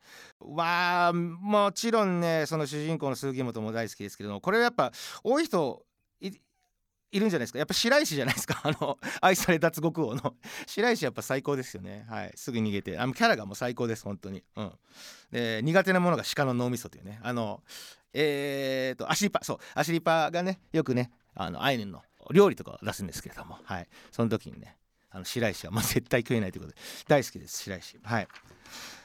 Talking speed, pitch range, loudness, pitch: 395 characters per minute, 115-175 Hz, -29 LUFS, 140 Hz